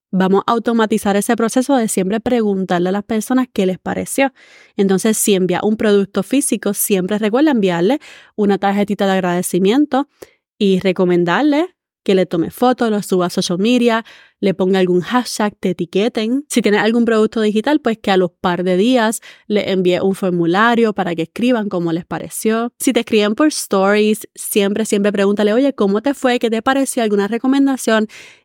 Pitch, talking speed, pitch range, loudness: 210 Hz, 175 wpm, 190-235 Hz, -16 LUFS